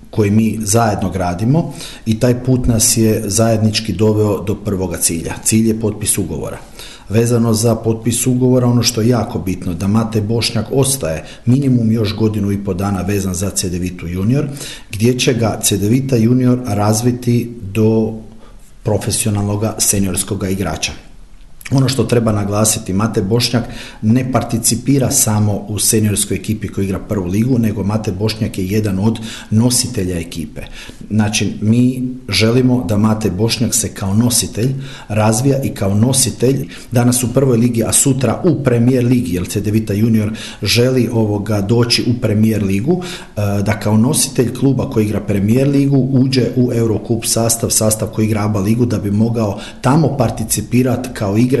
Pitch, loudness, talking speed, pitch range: 110 Hz, -15 LUFS, 150 wpm, 105-120 Hz